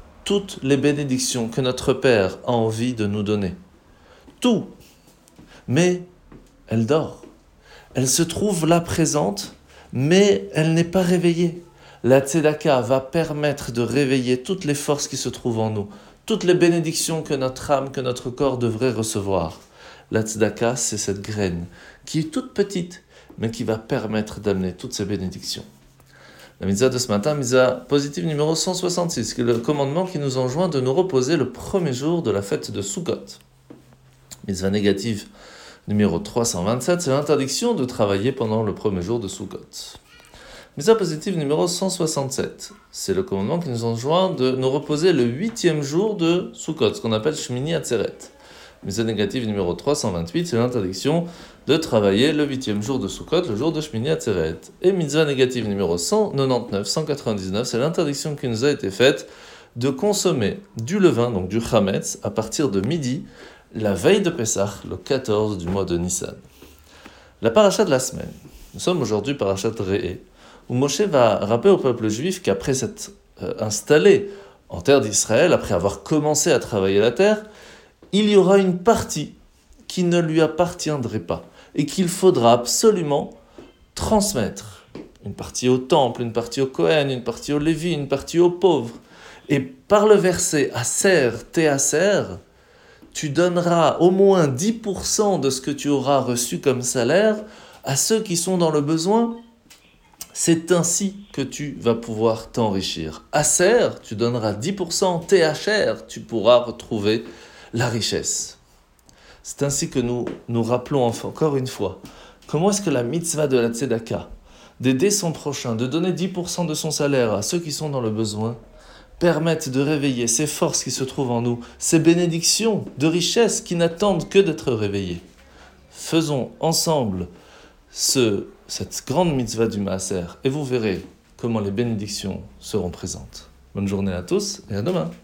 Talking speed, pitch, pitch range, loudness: 160 wpm, 135 Hz, 115-170 Hz, -21 LUFS